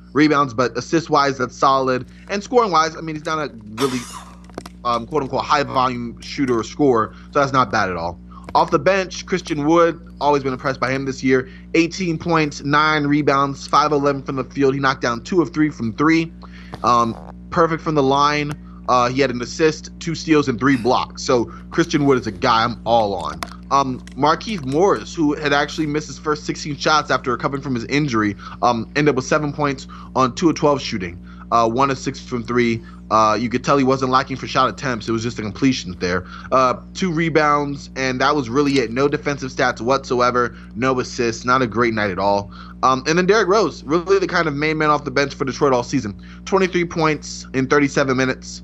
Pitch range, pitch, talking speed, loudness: 120-150 Hz, 135 Hz, 215 wpm, -19 LUFS